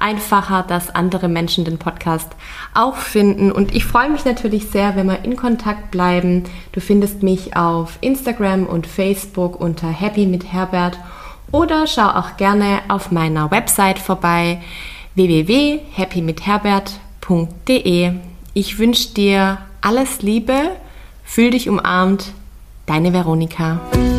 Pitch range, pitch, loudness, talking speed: 175-210 Hz, 195 Hz, -17 LUFS, 120 wpm